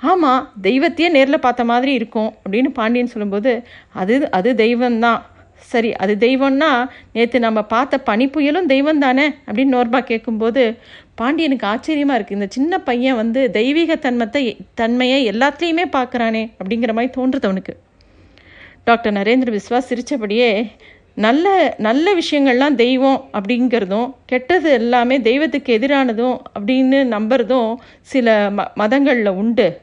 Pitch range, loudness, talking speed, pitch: 225-270 Hz, -16 LUFS, 120 wpm, 245 Hz